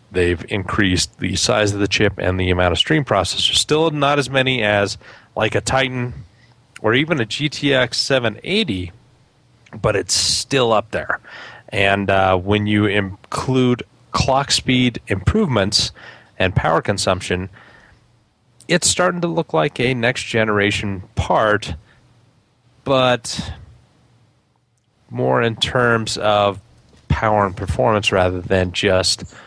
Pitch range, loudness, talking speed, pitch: 95-125 Hz, -18 LUFS, 125 wpm, 110 Hz